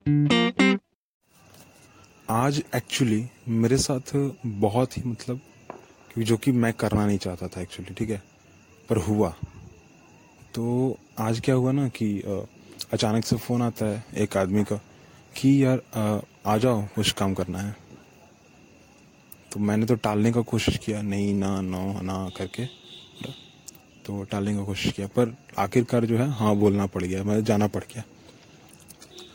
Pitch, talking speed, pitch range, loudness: 110 Hz, 145 wpm, 100-120 Hz, -25 LUFS